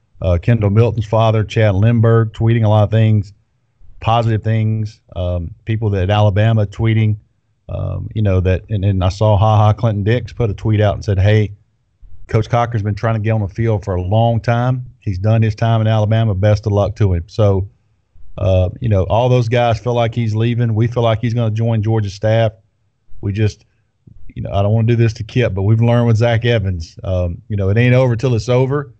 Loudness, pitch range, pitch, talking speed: -16 LUFS, 105-115 Hz, 110 Hz, 225 wpm